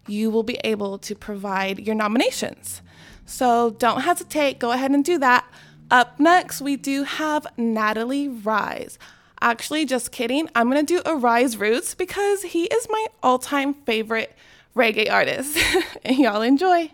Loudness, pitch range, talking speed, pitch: -21 LUFS, 225-310 Hz, 150 wpm, 255 Hz